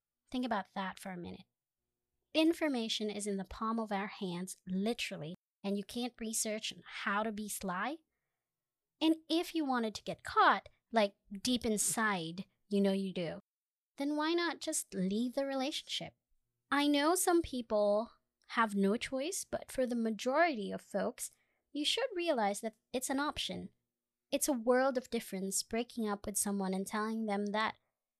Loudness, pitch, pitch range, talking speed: -35 LUFS, 225 Hz, 200-275 Hz, 165 wpm